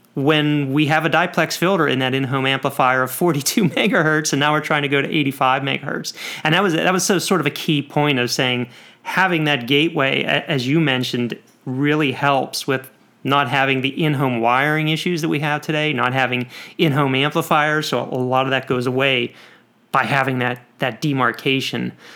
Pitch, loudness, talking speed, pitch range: 140 Hz, -18 LUFS, 185 wpm, 130-155 Hz